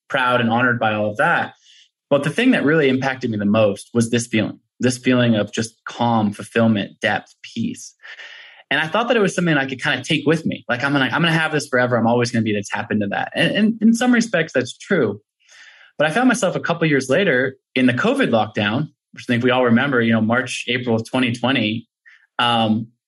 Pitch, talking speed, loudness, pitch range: 125 Hz, 235 wpm, -18 LUFS, 115-145 Hz